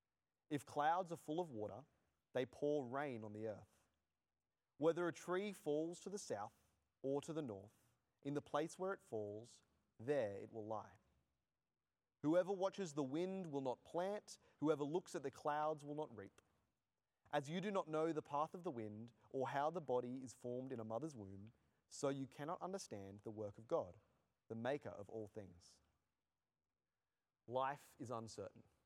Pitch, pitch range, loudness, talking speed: 130 Hz, 105-155 Hz, -46 LUFS, 175 wpm